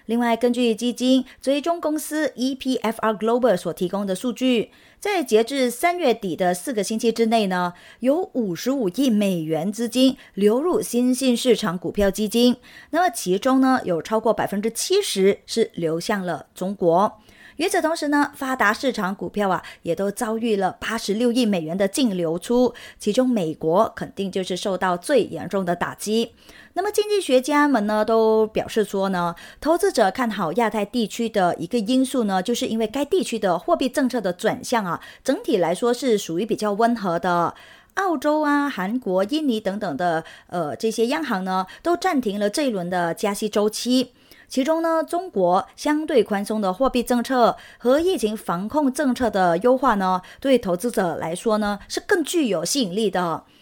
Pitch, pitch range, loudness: 230 Hz, 195-260 Hz, -22 LUFS